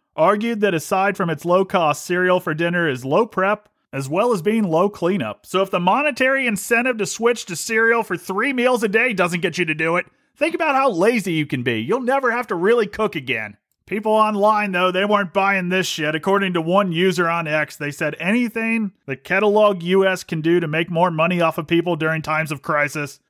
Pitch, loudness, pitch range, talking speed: 190 Hz, -19 LUFS, 165-215 Hz, 220 wpm